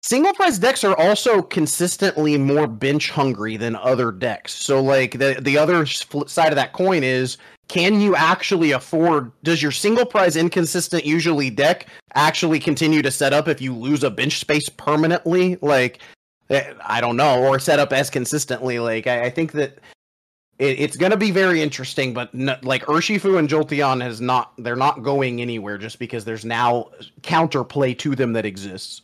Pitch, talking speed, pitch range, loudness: 145 Hz, 180 wpm, 125-165 Hz, -19 LUFS